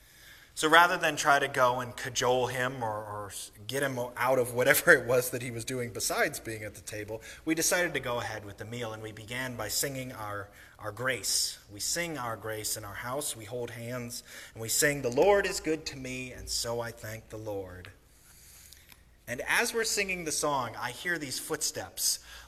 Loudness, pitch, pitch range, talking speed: -29 LUFS, 120 Hz, 105-135 Hz, 210 wpm